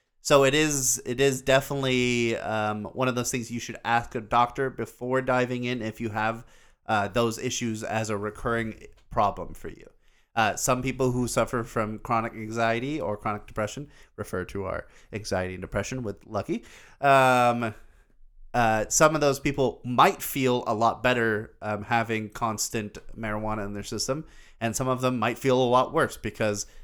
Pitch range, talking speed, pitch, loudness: 110-130 Hz, 175 wpm, 115 Hz, -26 LUFS